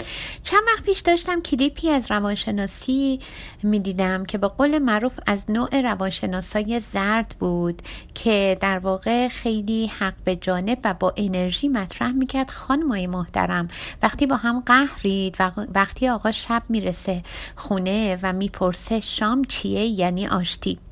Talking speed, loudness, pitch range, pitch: 140 wpm, -22 LUFS, 190-250 Hz, 210 Hz